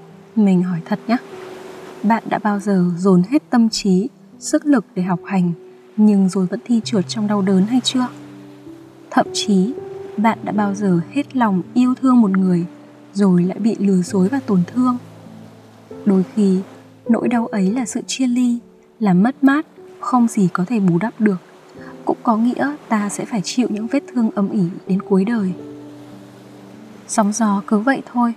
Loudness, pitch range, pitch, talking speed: -18 LUFS, 185-240 Hz, 205 Hz, 180 wpm